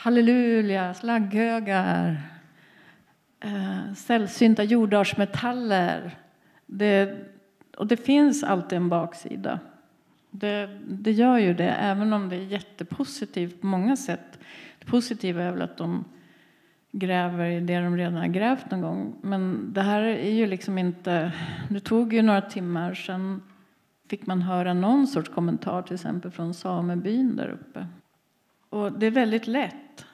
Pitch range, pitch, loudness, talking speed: 180-225 Hz, 200 Hz, -25 LUFS, 135 wpm